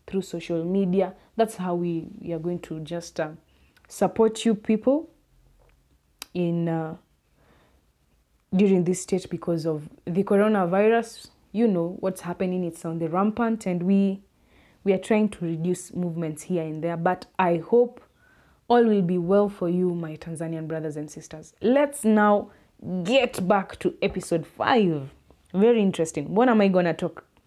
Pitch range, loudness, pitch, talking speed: 165-205 Hz, -24 LUFS, 180 Hz, 155 wpm